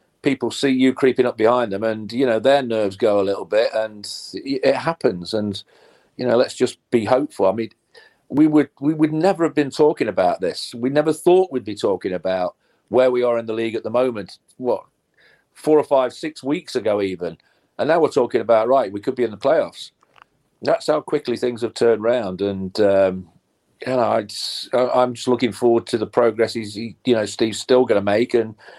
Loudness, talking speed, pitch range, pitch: -20 LUFS, 215 wpm, 110-135 Hz, 120 Hz